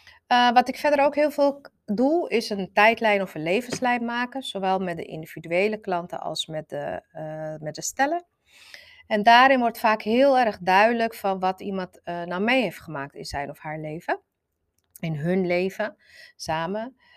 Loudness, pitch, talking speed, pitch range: -23 LUFS, 200 Hz, 180 wpm, 160-245 Hz